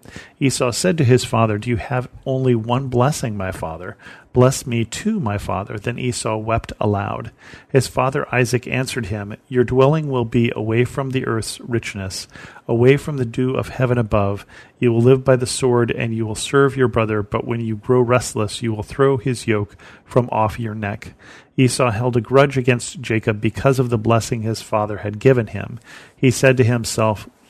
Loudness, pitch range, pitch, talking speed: -19 LUFS, 110-130 Hz, 120 Hz, 190 wpm